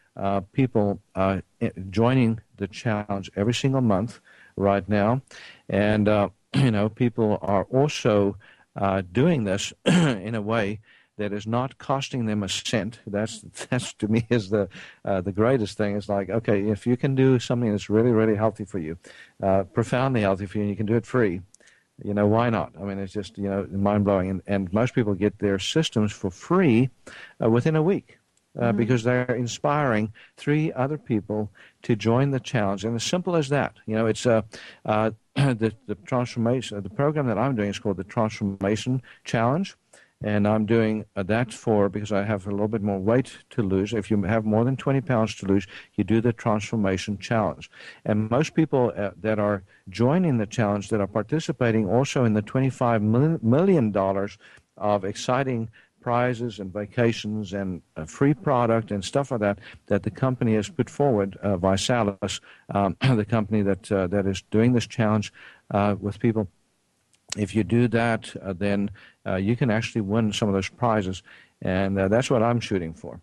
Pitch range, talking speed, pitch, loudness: 100-120 Hz, 185 wpm, 110 Hz, -24 LUFS